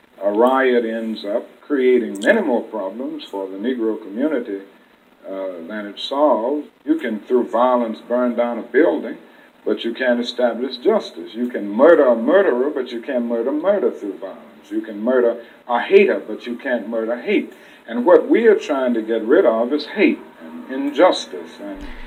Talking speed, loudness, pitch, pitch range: 175 wpm, -18 LUFS, 120 Hz, 110-145 Hz